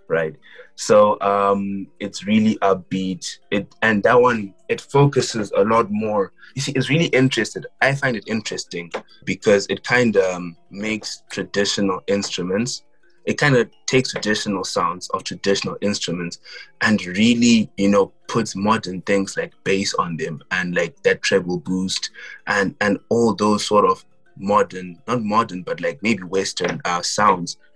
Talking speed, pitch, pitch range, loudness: 155 wpm, 105 Hz, 95-115 Hz, -20 LUFS